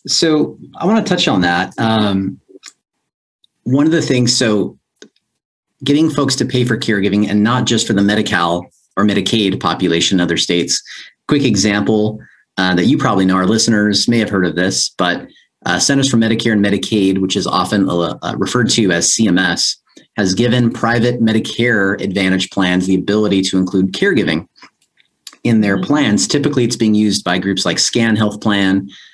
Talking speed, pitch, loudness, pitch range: 170 wpm, 105 Hz, -14 LUFS, 95-120 Hz